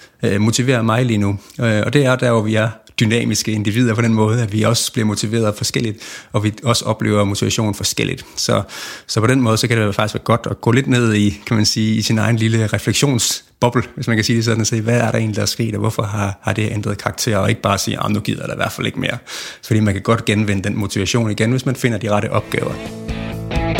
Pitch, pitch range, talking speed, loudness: 110 Hz, 105-120 Hz, 255 wpm, -17 LUFS